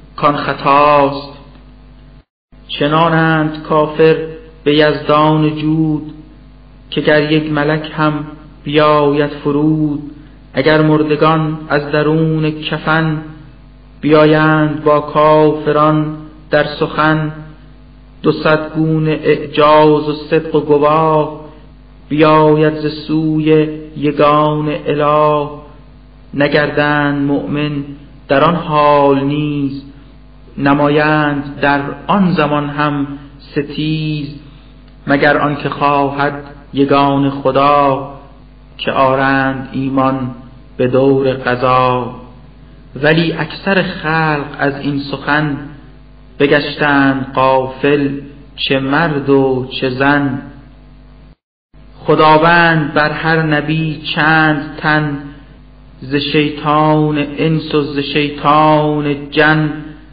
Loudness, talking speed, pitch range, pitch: -13 LUFS, 85 wpm, 140-155 Hz, 150 Hz